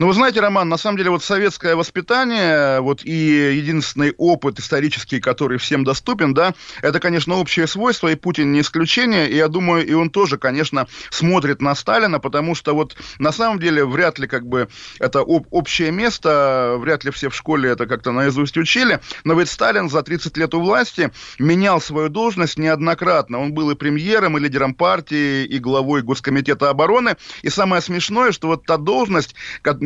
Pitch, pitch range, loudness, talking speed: 160 Hz, 140-175 Hz, -17 LUFS, 180 wpm